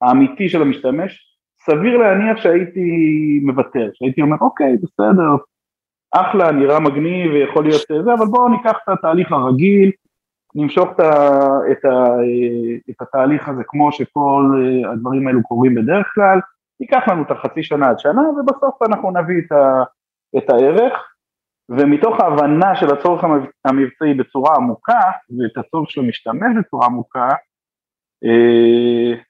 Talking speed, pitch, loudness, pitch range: 130 wpm, 145 Hz, -15 LUFS, 130-185 Hz